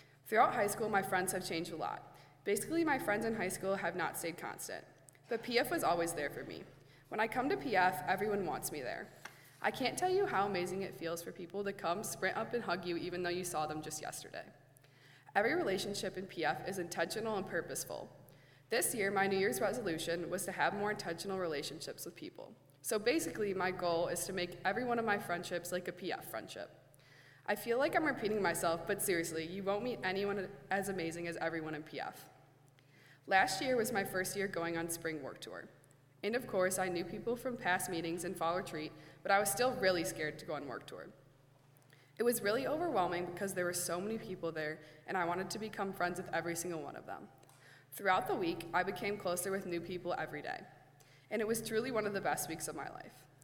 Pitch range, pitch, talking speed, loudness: 165-200 Hz, 180 Hz, 220 wpm, -37 LUFS